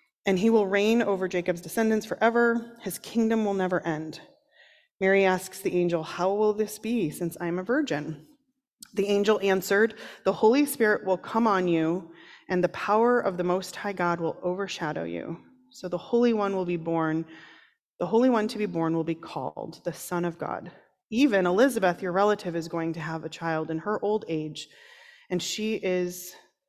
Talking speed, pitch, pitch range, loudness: 190 wpm, 190 Hz, 170-225 Hz, -26 LUFS